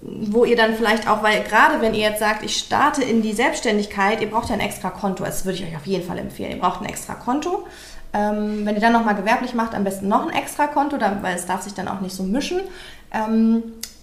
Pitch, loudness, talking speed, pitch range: 220 Hz, -21 LUFS, 240 wpm, 200-235 Hz